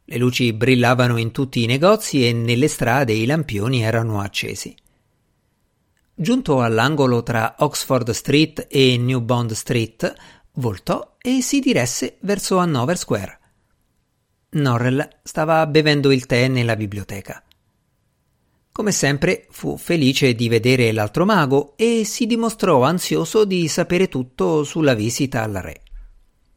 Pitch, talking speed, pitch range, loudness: 130 Hz, 125 wpm, 115-160 Hz, -18 LUFS